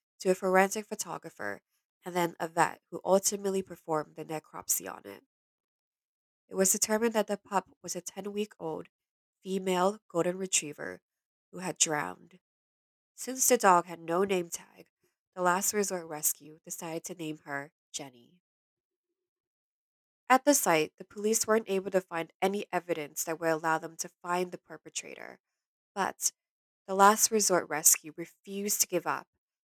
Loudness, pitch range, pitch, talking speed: -30 LUFS, 165-200 Hz, 180 Hz, 155 wpm